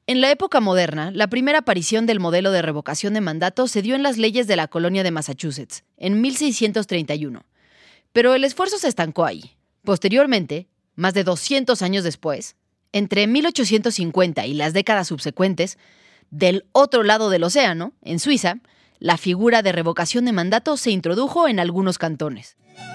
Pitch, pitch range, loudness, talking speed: 195 Hz, 170-240 Hz, -20 LUFS, 160 wpm